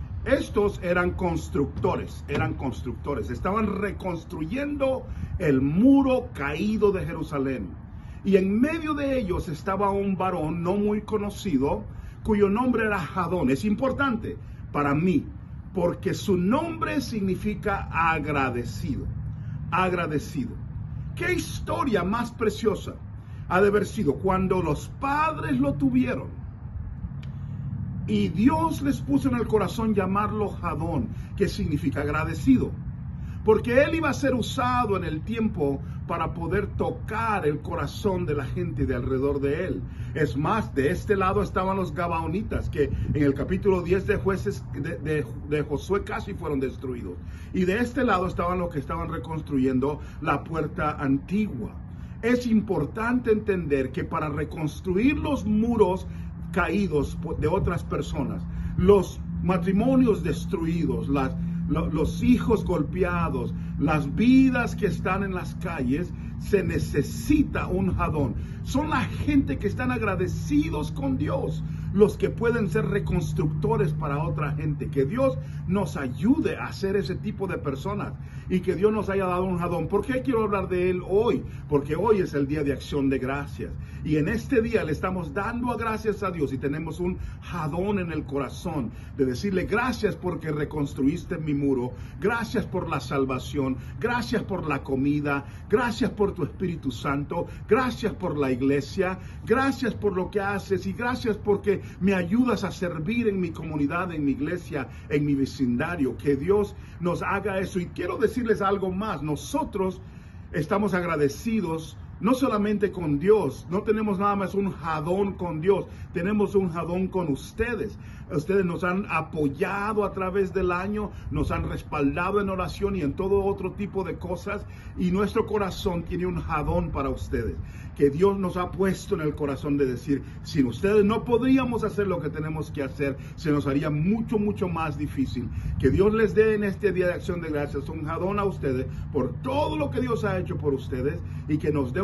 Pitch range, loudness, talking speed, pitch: 140-205 Hz, -26 LUFS, 160 wpm, 175 Hz